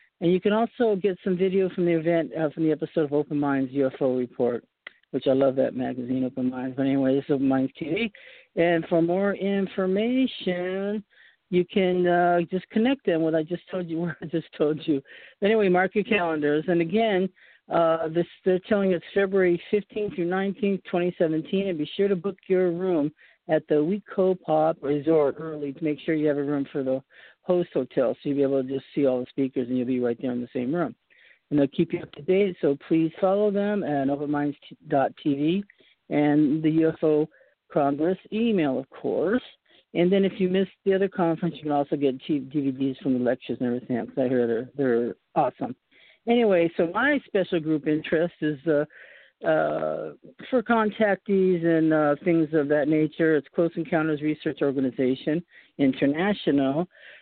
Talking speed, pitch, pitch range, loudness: 190 wpm, 165 Hz, 145-185 Hz, -25 LUFS